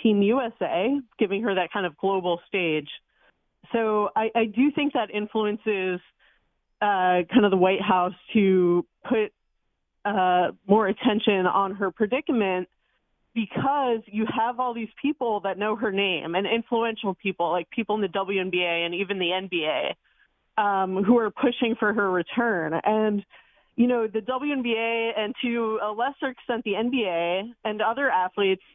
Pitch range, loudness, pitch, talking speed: 185-230 Hz, -25 LUFS, 210 Hz, 155 wpm